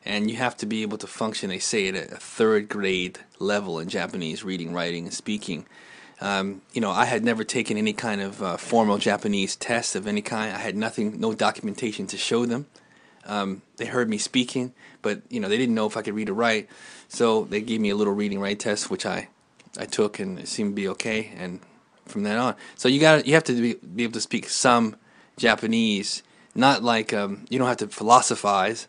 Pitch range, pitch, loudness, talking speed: 100-120 Hz, 110 Hz, -24 LUFS, 220 wpm